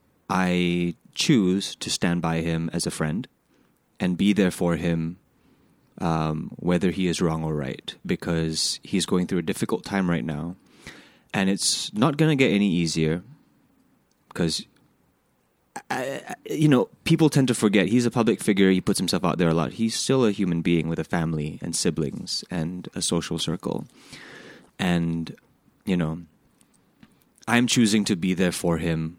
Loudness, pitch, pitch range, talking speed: -24 LUFS, 85 Hz, 80-100 Hz, 170 wpm